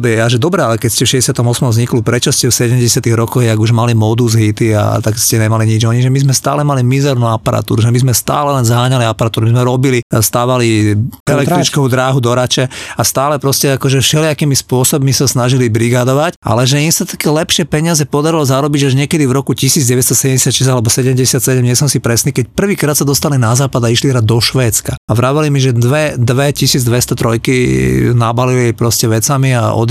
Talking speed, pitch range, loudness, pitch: 200 wpm, 115-140 Hz, -11 LUFS, 130 Hz